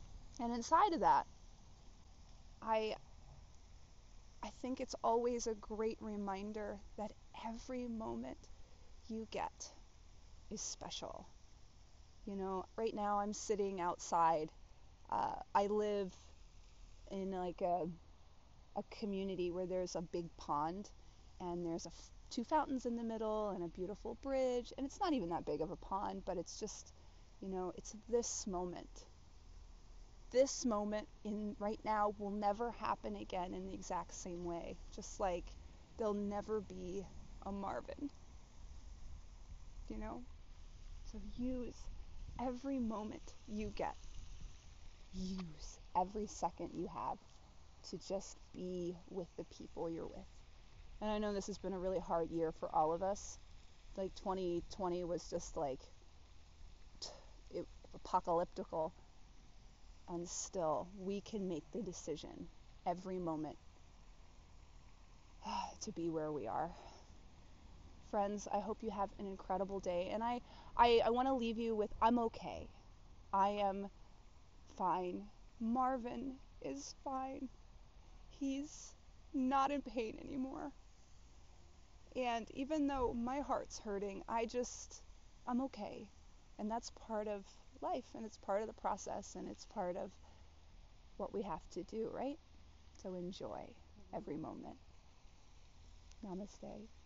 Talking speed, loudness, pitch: 130 wpm, -42 LUFS, 195 Hz